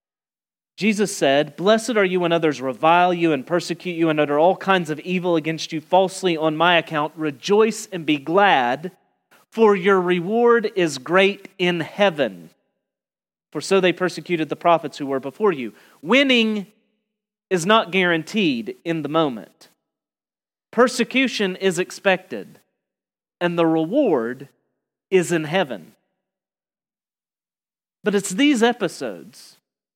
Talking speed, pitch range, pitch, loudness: 130 wpm, 165-205 Hz, 185 Hz, -20 LUFS